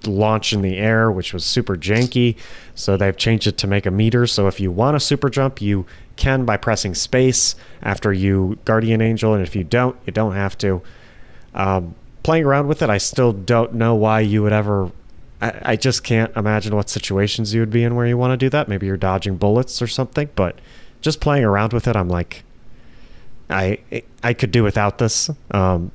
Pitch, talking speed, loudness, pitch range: 110 Hz, 210 wpm, -18 LUFS, 100-120 Hz